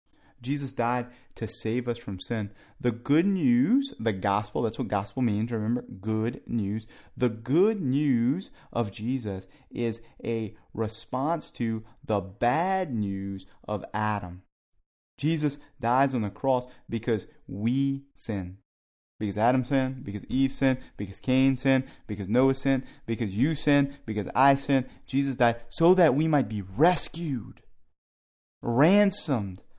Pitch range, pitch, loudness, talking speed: 105-135 Hz, 120 Hz, -27 LUFS, 135 wpm